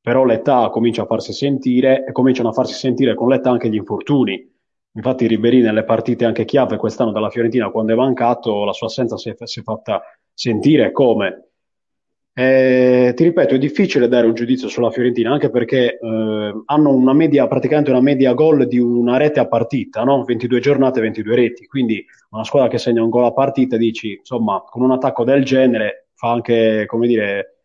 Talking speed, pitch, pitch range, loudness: 185 wpm, 120 Hz, 115-130 Hz, -16 LUFS